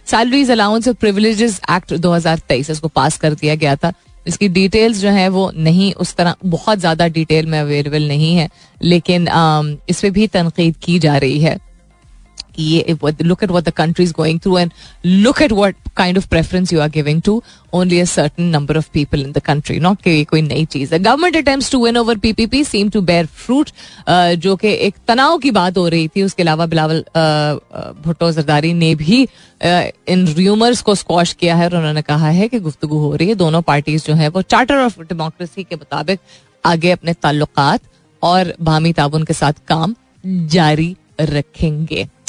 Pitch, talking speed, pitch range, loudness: 170 Hz, 175 wpm, 155-195 Hz, -14 LUFS